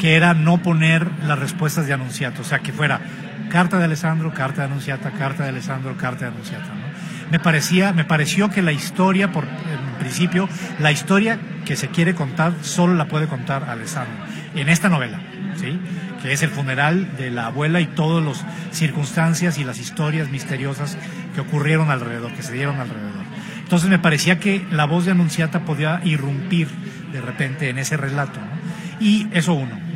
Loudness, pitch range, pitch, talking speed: -20 LUFS, 145-175 Hz, 160 Hz, 180 wpm